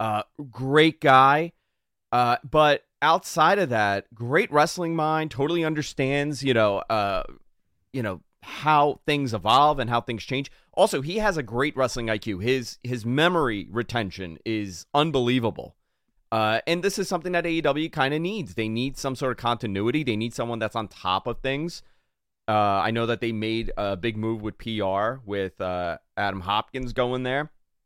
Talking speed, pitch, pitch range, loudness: 170 wpm, 125 Hz, 110-145 Hz, -24 LUFS